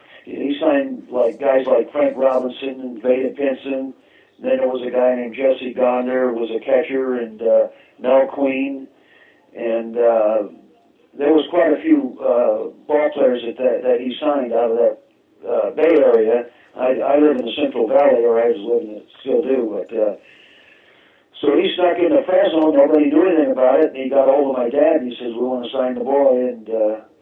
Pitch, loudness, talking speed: 135 Hz, -18 LUFS, 205 wpm